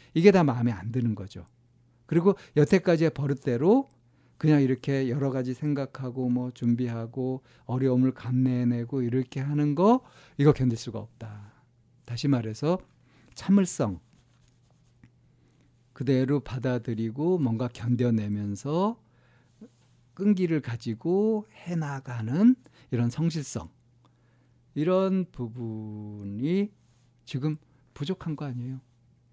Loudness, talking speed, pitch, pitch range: -27 LUFS, 240 characters per minute, 130 Hz, 120-150 Hz